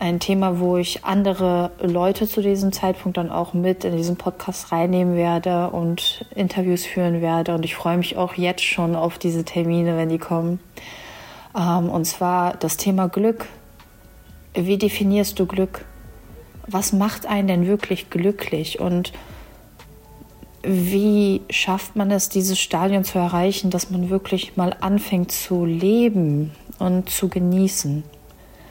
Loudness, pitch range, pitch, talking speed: -21 LUFS, 175-195 Hz, 180 Hz, 140 wpm